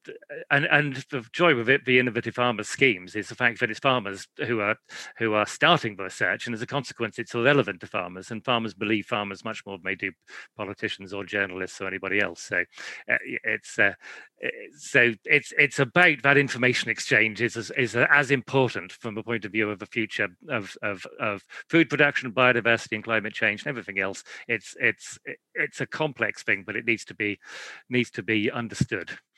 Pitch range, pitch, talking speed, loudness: 105-130 Hz, 115 Hz, 195 wpm, -25 LUFS